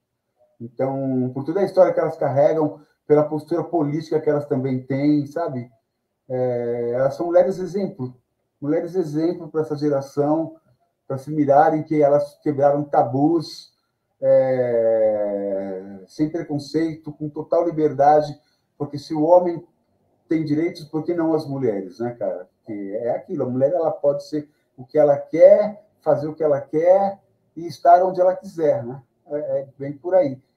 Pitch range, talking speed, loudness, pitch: 135-165 Hz, 155 wpm, -20 LUFS, 150 Hz